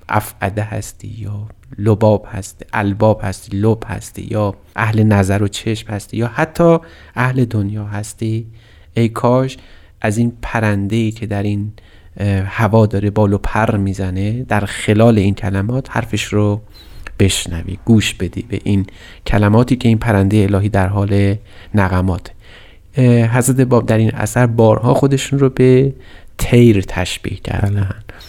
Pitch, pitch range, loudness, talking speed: 105 Hz, 100-115 Hz, -15 LUFS, 140 wpm